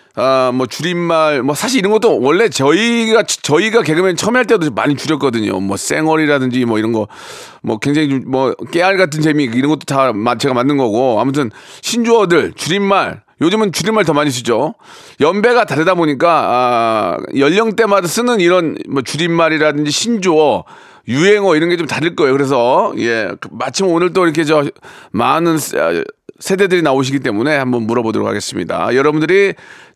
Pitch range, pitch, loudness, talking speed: 135-190 Hz, 155 Hz, -13 LUFS, 355 characters per minute